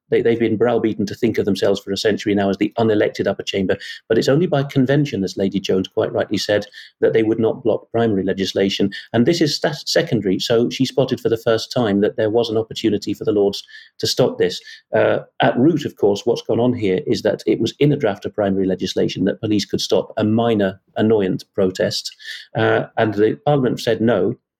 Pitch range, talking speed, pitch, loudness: 100-130 Hz, 220 wpm, 110 Hz, -19 LUFS